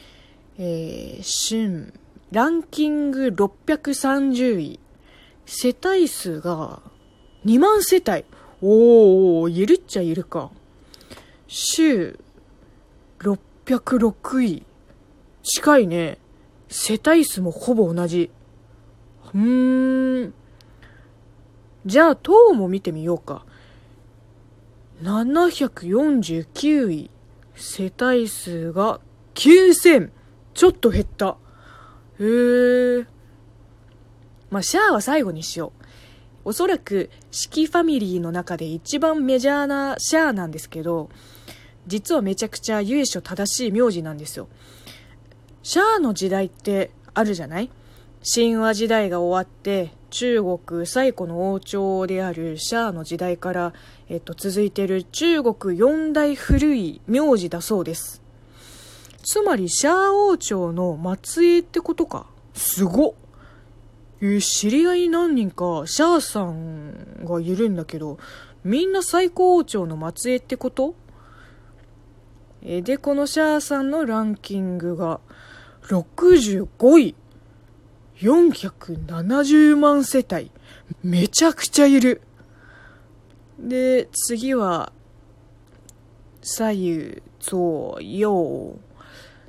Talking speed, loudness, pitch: 185 characters per minute, -20 LUFS, 195 Hz